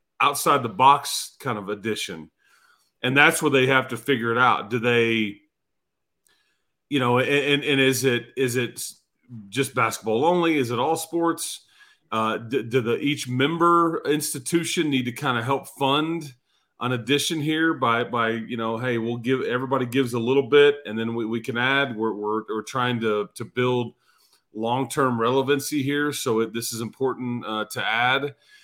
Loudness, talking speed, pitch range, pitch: -23 LUFS, 175 wpm, 115-145 Hz, 130 Hz